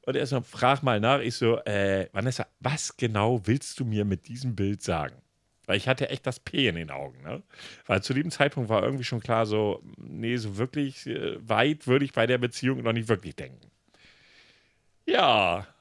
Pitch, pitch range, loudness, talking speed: 120 Hz, 105-130 Hz, -27 LUFS, 195 wpm